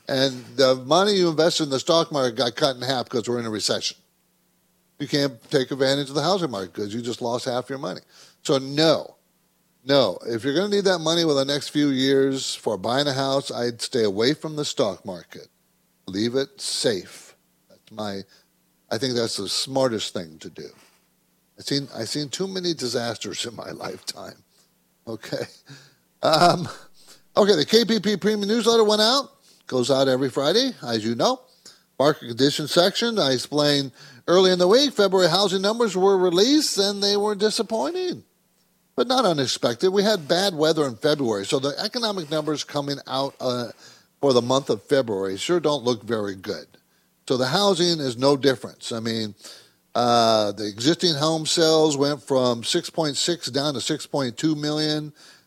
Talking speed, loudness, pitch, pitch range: 180 wpm, -22 LUFS, 145 Hz, 130-180 Hz